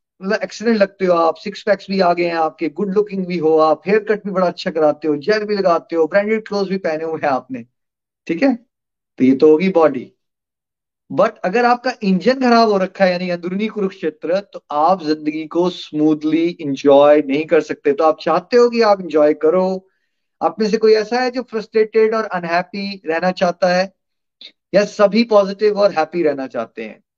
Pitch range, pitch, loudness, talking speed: 160-210 Hz, 185 Hz, -16 LUFS, 200 wpm